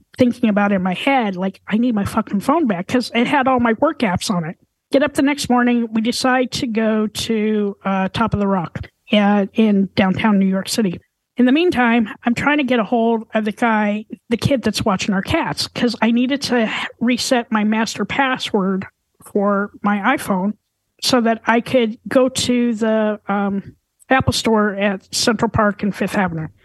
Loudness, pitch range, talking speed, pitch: -18 LUFS, 205-245 Hz, 200 wpm, 225 Hz